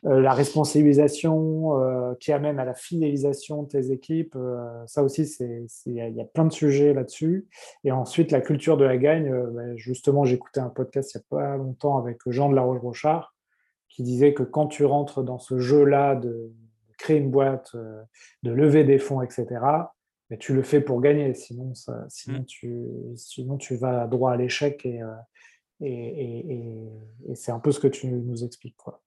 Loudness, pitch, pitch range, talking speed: -24 LUFS, 130 Hz, 125-145 Hz, 195 wpm